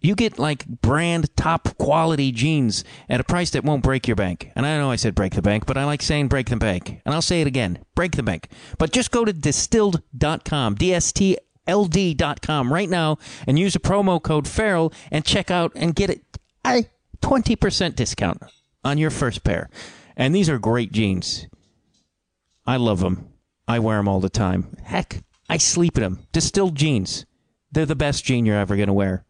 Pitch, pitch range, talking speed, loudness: 145 Hz, 110-170 Hz, 195 wpm, -21 LUFS